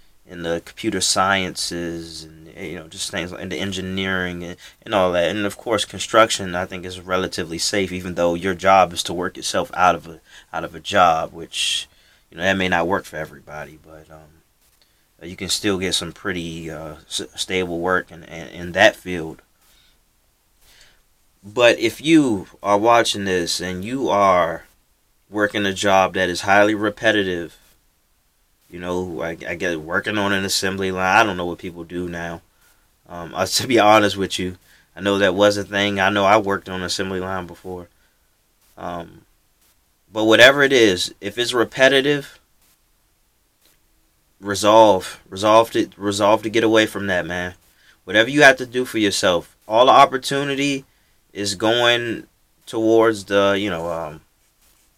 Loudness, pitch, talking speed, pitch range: -18 LUFS, 95 Hz, 170 wpm, 85-105 Hz